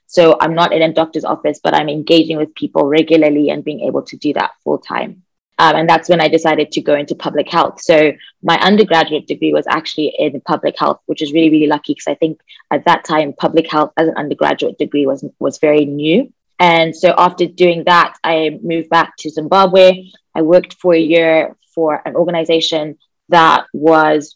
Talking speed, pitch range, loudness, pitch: 200 wpm, 150-170 Hz, -13 LUFS, 160 Hz